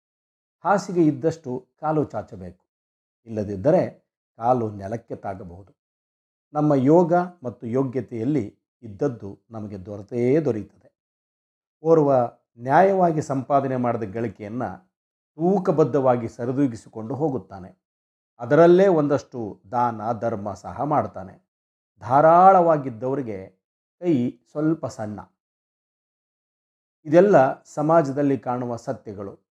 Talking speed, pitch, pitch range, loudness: 75 wpm, 120 Hz, 105-150 Hz, -21 LUFS